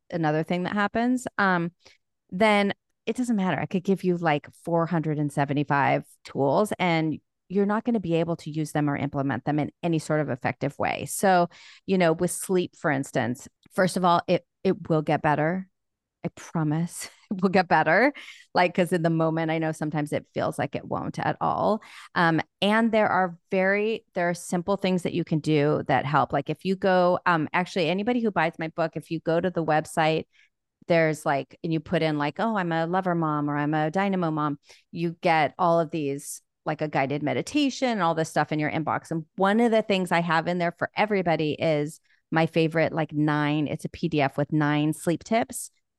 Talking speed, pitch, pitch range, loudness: 205 wpm, 165 Hz, 155-185 Hz, -25 LUFS